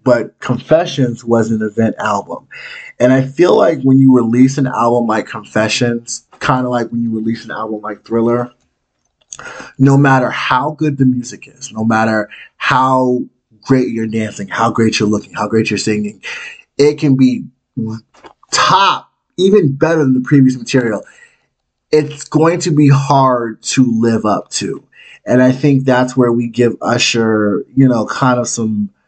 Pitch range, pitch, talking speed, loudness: 110-135 Hz, 125 Hz, 165 wpm, -13 LUFS